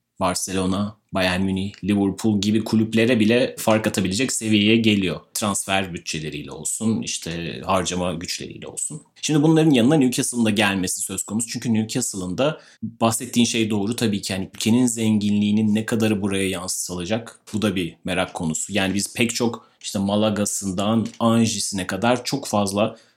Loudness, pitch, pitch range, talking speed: -21 LUFS, 105 Hz, 95-115 Hz, 145 wpm